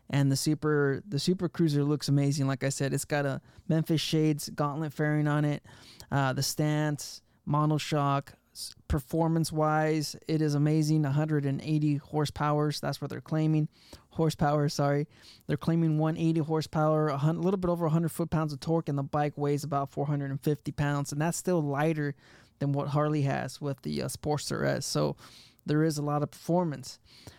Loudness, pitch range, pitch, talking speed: -29 LUFS, 140-155 Hz, 150 Hz, 165 wpm